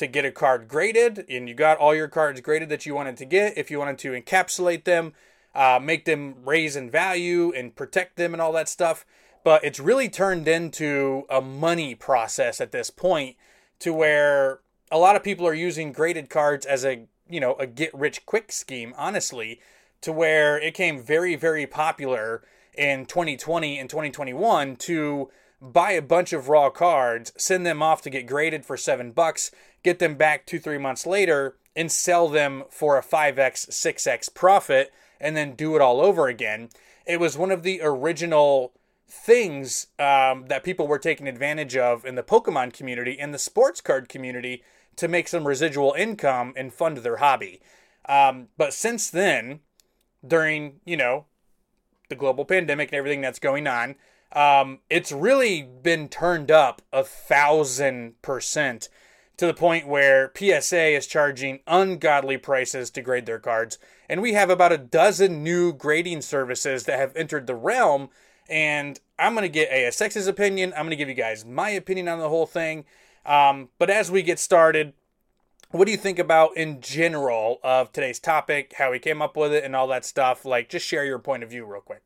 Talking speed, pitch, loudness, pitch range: 185 wpm, 150 Hz, -22 LUFS, 135-170 Hz